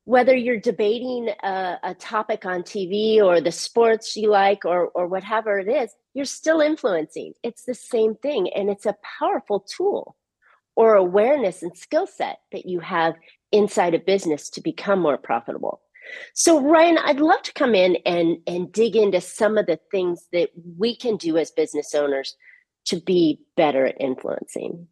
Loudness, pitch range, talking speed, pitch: -21 LUFS, 175-240 Hz, 175 wpm, 205 Hz